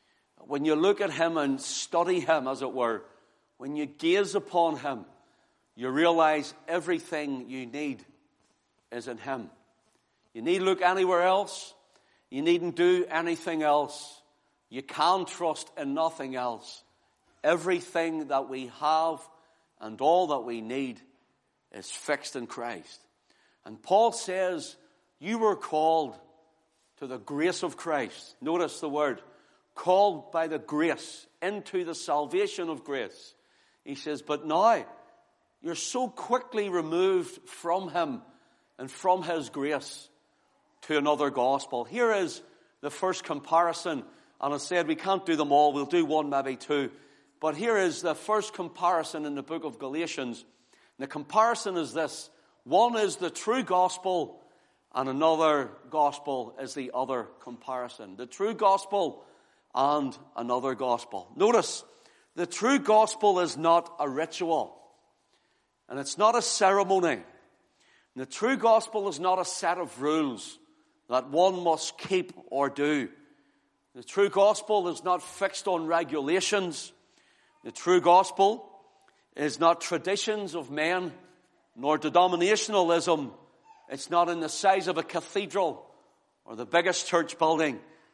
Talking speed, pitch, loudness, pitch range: 140 wpm, 165 Hz, -28 LUFS, 145-190 Hz